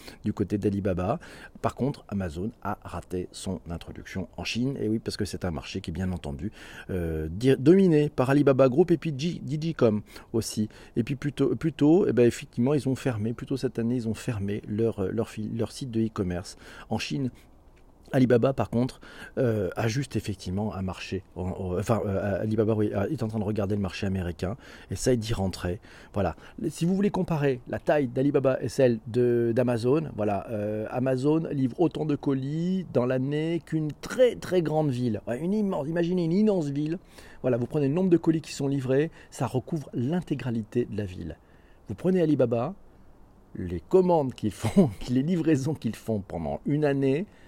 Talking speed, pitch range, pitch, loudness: 185 wpm, 105-145 Hz, 120 Hz, -27 LUFS